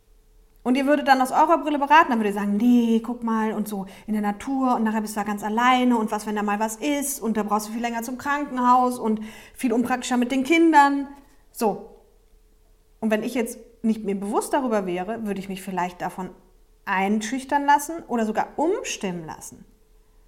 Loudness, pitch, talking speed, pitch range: -23 LUFS, 230 Hz, 205 wpm, 210-265 Hz